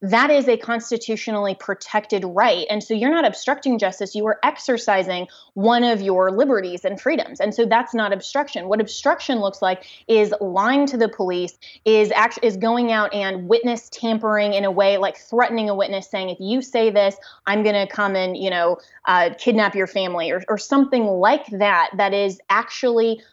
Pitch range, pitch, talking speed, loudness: 195-235 Hz, 210 Hz, 190 wpm, -20 LUFS